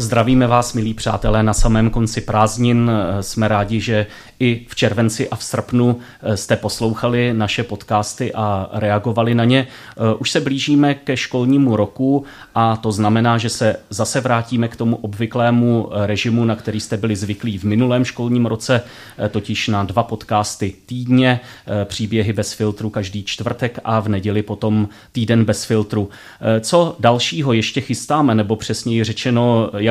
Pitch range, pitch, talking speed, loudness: 105-120 Hz, 115 Hz, 155 wpm, -18 LUFS